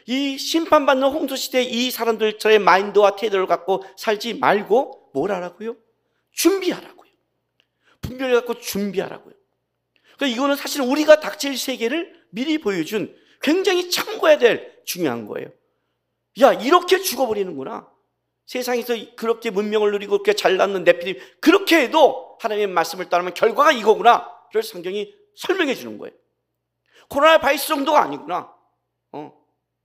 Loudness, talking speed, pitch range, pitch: -19 LUFS, 335 characters per minute, 215-325 Hz, 260 Hz